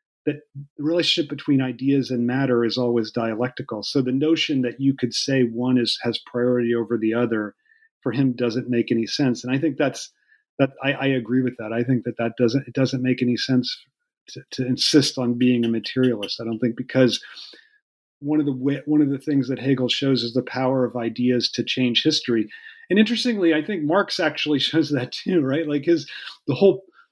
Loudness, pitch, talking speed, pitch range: -22 LUFS, 130 Hz, 205 wpm, 120-145 Hz